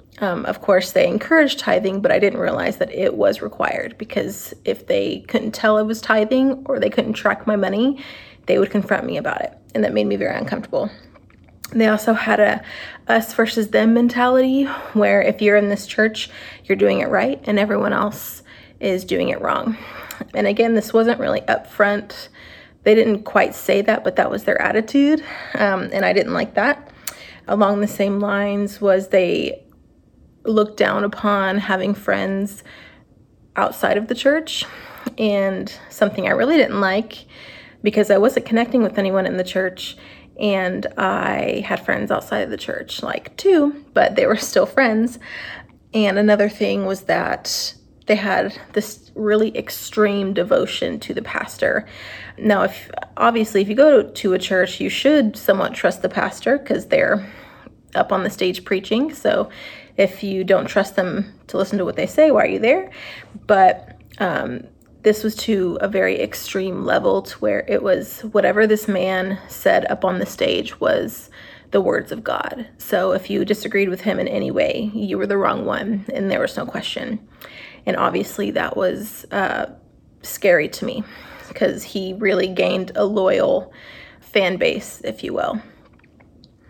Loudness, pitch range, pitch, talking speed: -19 LUFS, 195-230 Hz, 210 Hz, 170 wpm